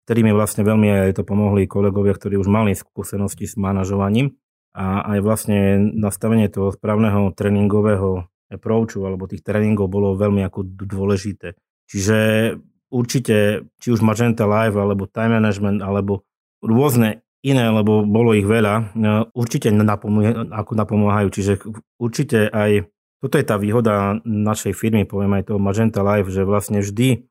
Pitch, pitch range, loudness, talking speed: 105 Hz, 100-110 Hz, -18 LUFS, 145 wpm